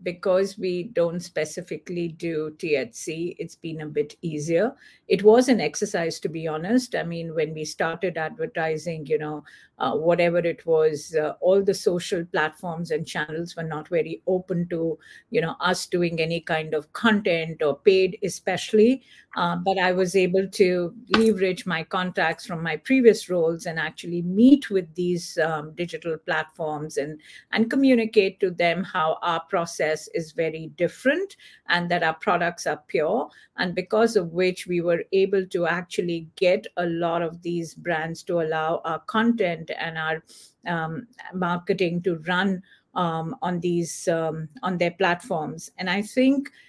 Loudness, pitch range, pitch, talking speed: -24 LUFS, 160-190 Hz, 175 Hz, 160 wpm